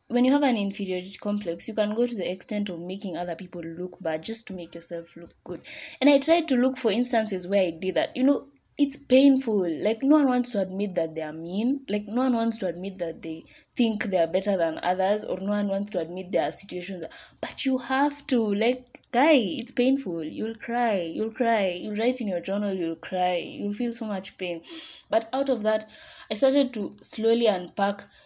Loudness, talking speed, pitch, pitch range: -26 LUFS, 225 wpm, 210 Hz, 180-245 Hz